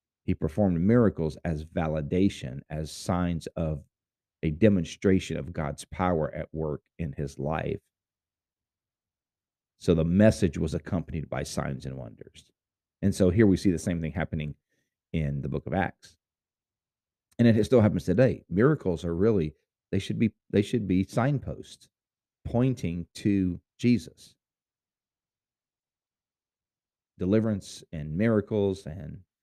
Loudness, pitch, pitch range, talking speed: -27 LUFS, 90 Hz, 80-100 Hz, 130 wpm